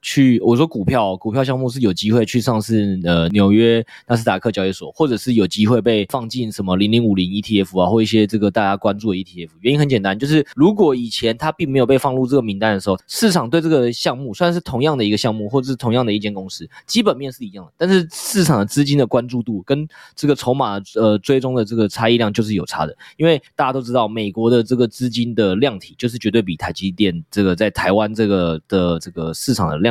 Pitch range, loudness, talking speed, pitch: 100-130 Hz, -17 LUFS, 375 characters per minute, 115 Hz